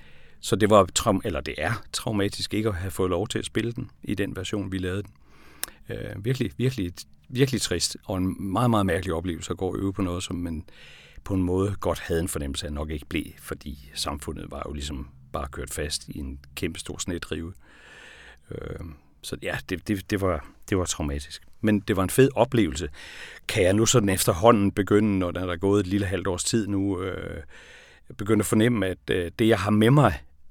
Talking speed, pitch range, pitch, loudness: 210 wpm, 80-105 Hz, 95 Hz, -26 LUFS